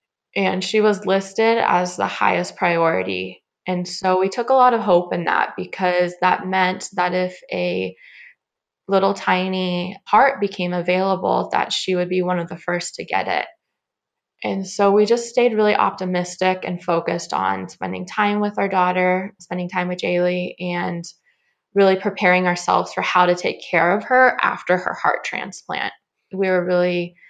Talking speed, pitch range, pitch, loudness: 170 wpm, 180-200 Hz, 185 Hz, -20 LUFS